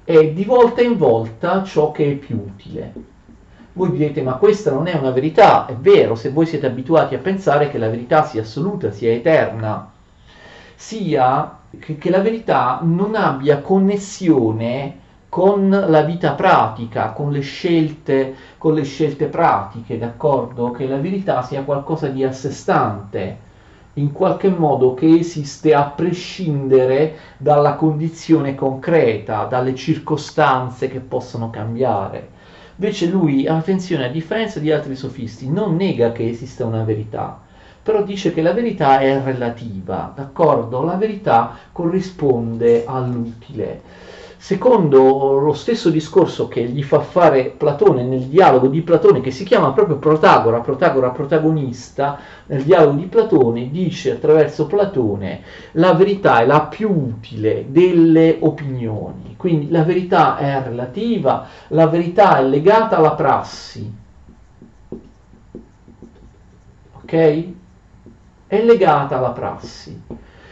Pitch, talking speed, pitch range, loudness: 150 Hz, 130 wpm, 125-170 Hz, -16 LUFS